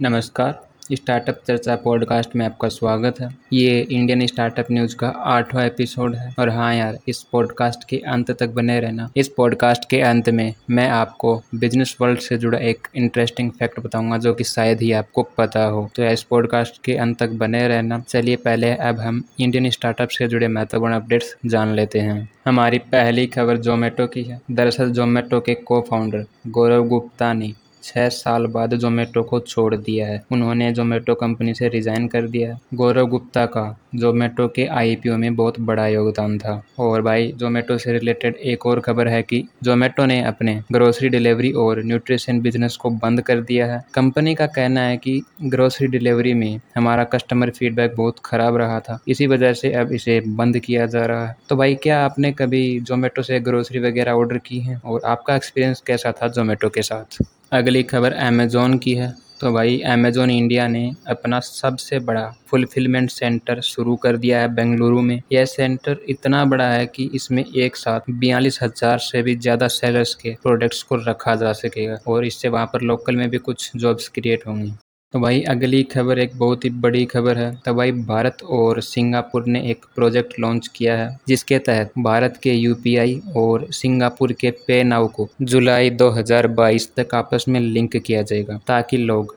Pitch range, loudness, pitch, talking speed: 115-125 Hz, -19 LUFS, 120 Hz, 185 wpm